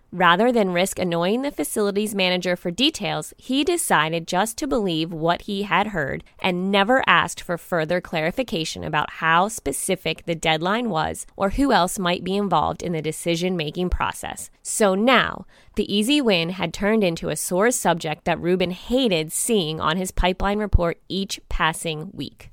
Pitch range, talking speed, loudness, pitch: 165-210 Hz, 170 wpm, -22 LUFS, 180 Hz